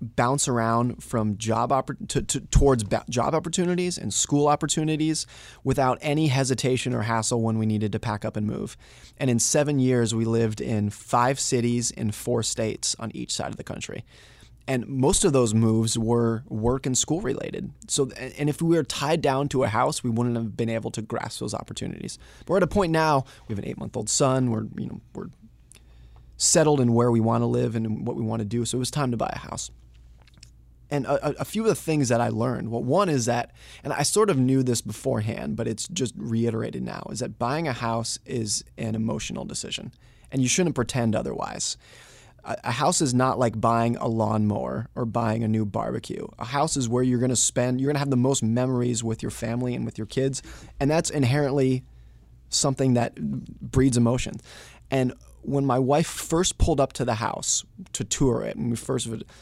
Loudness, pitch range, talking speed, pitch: -25 LUFS, 115-140 Hz, 215 wpm, 120 Hz